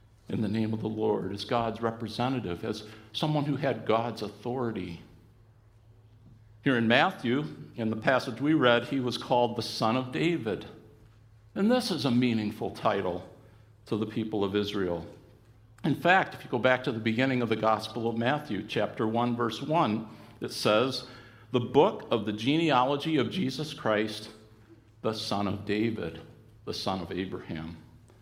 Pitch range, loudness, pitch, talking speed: 110-125 Hz, -29 LUFS, 110 Hz, 165 wpm